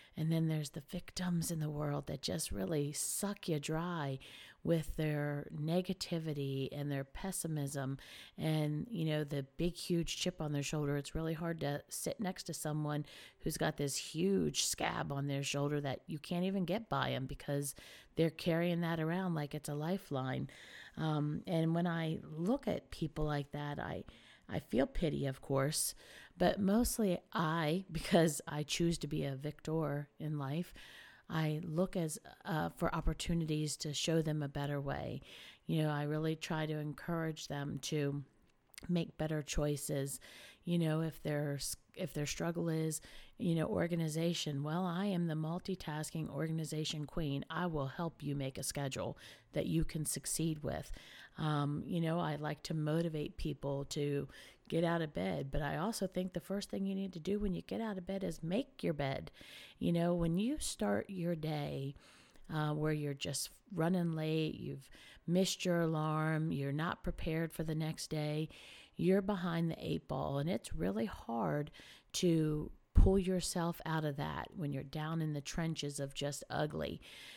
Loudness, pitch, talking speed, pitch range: -38 LUFS, 155 Hz, 175 wpm, 145-170 Hz